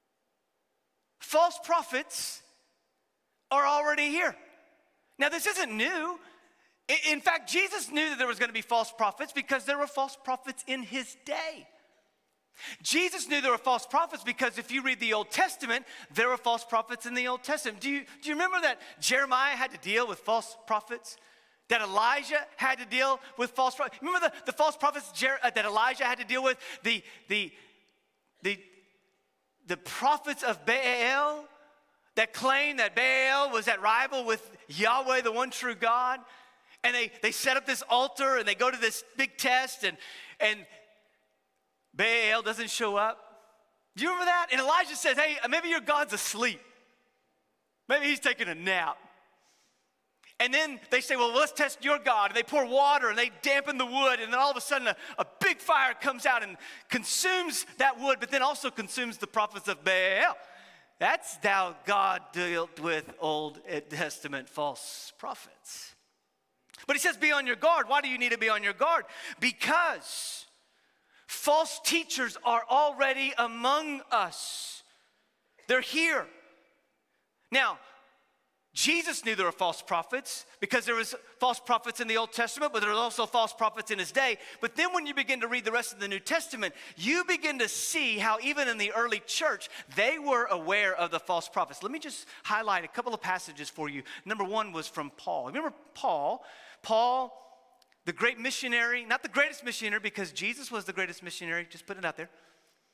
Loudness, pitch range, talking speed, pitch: -29 LUFS, 220-285 Hz, 180 wpm, 250 Hz